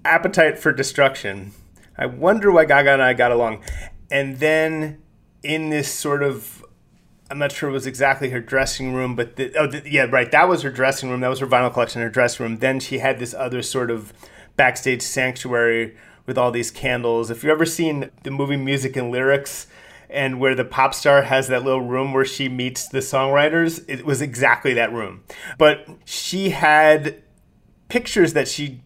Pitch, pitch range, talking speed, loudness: 135 Hz, 125-150 Hz, 190 wpm, -19 LUFS